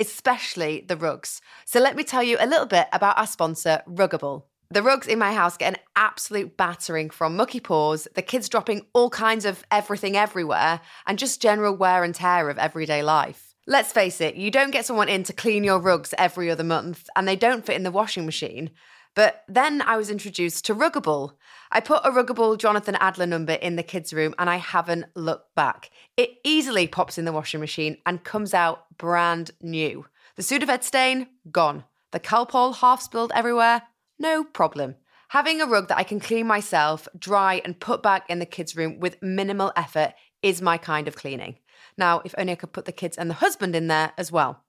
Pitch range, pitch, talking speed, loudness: 165-225 Hz, 185 Hz, 205 wpm, -23 LUFS